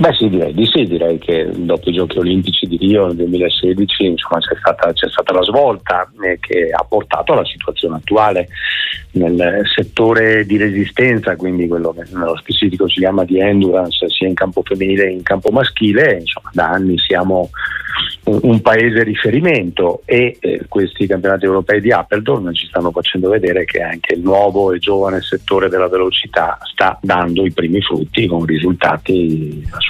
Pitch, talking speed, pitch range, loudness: 95 Hz, 170 wpm, 85-100 Hz, -14 LUFS